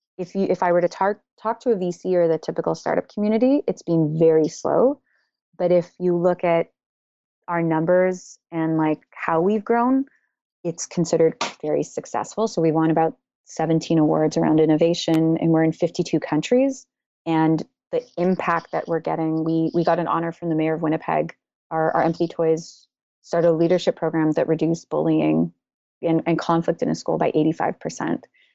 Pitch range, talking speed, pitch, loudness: 160-180 Hz, 175 wpm, 165 Hz, -21 LUFS